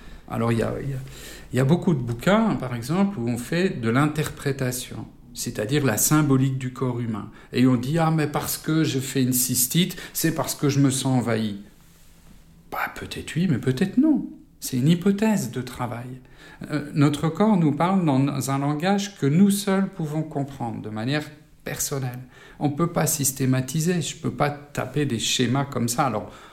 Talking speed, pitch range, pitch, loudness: 190 wpm, 125-160 Hz, 140 Hz, -23 LUFS